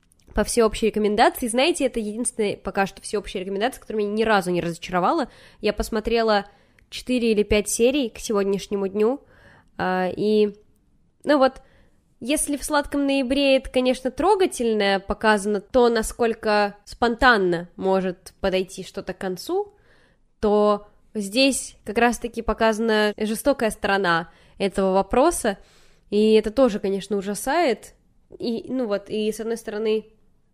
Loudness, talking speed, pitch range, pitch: -22 LUFS, 130 wpm, 200-245 Hz, 215 Hz